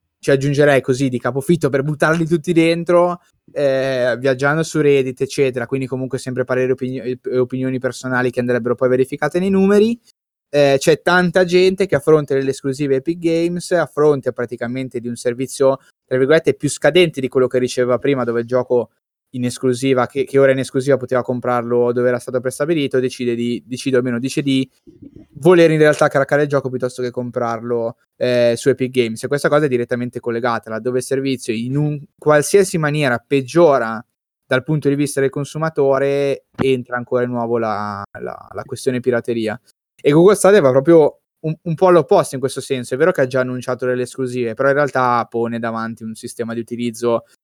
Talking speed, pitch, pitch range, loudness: 185 wpm, 130 Hz, 125-145 Hz, -17 LUFS